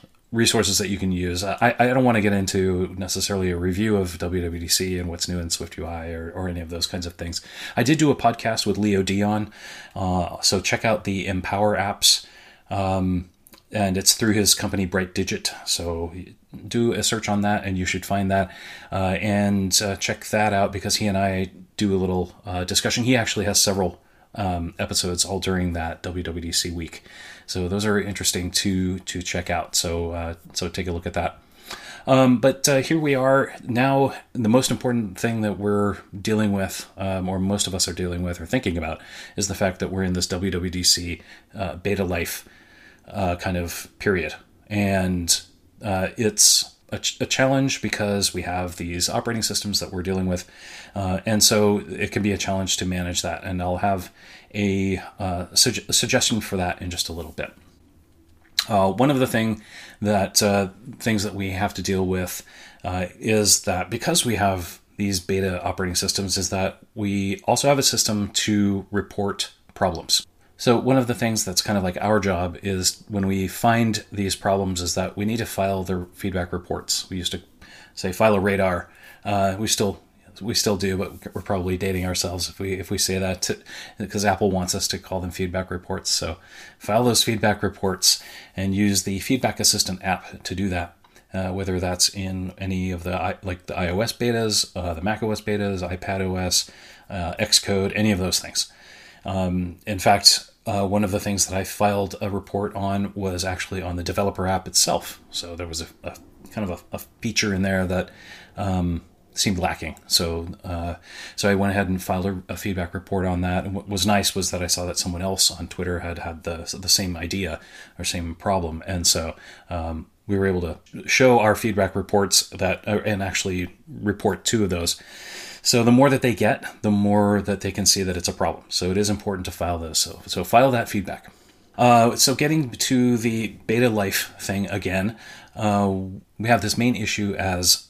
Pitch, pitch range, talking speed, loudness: 95 Hz, 90-105 Hz, 200 wpm, -22 LUFS